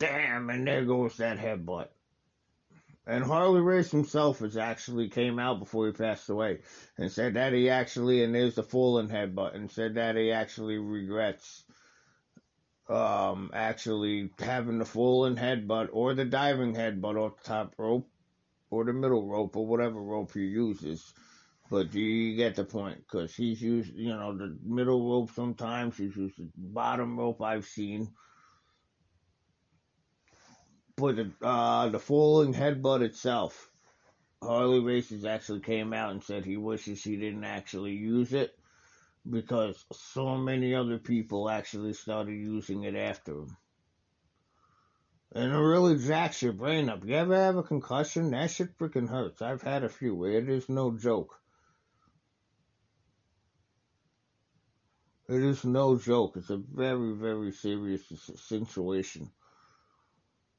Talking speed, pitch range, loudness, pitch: 145 wpm, 105-125 Hz, -30 LUFS, 115 Hz